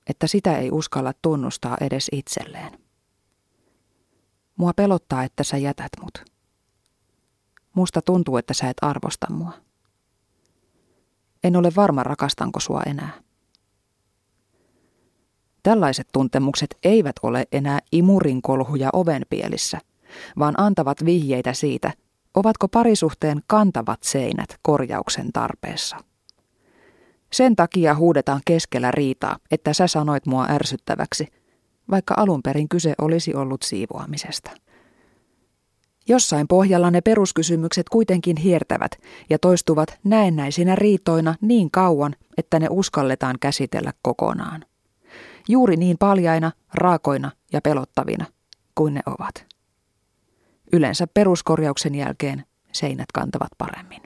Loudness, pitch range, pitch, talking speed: -21 LUFS, 135-180 Hz, 155 Hz, 100 wpm